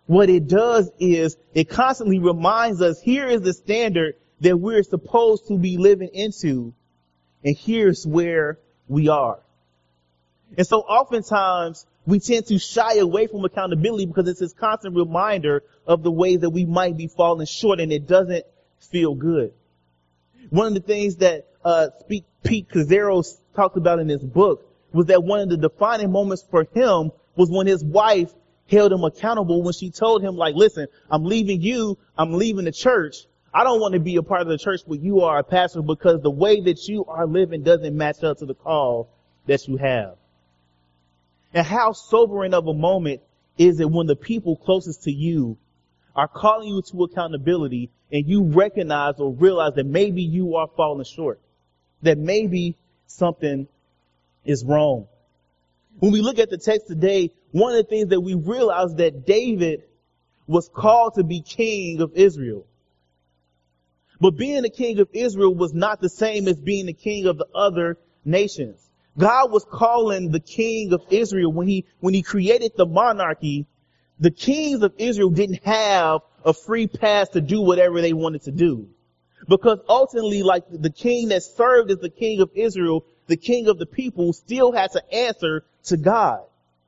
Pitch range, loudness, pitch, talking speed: 155-205 Hz, -20 LUFS, 180 Hz, 175 wpm